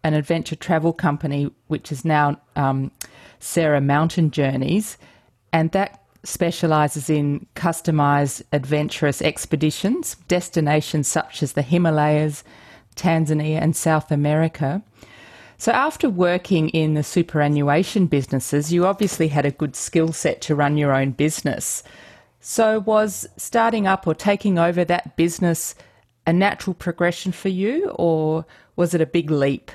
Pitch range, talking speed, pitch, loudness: 150-175 Hz, 135 wpm, 160 Hz, -21 LUFS